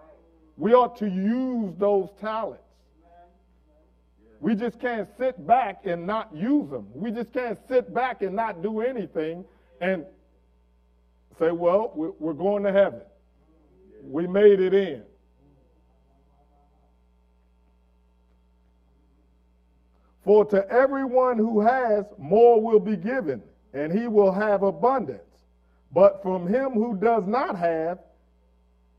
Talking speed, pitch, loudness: 115 wpm, 190 Hz, -23 LUFS